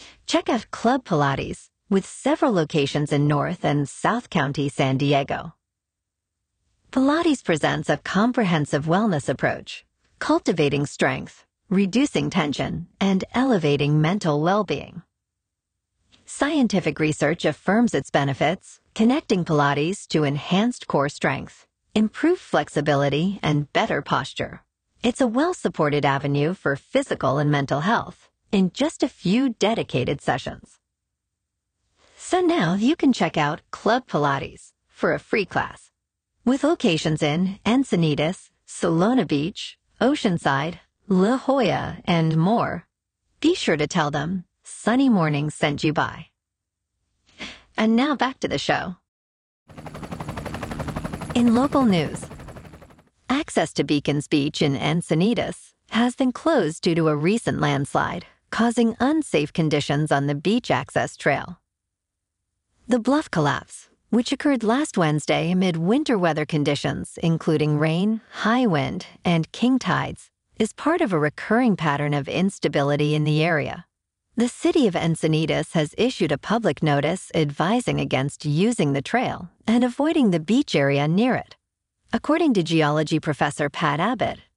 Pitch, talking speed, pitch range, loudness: 170 Hz, 130 wpm, 145-235 Hz, -22 LUFS